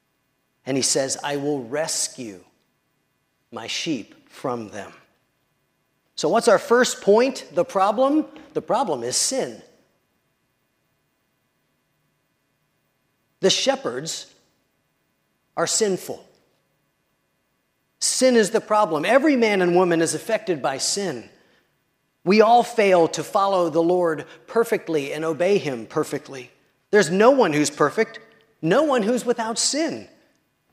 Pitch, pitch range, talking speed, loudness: 190 Hz, 155-230 Hz, 115 wpm, -21 LUFS